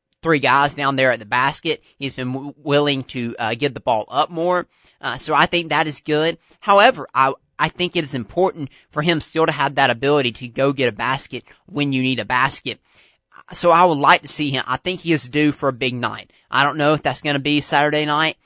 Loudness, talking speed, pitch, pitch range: -19 LUFS, 240 wpm, 145 Hz, 135-160 Hz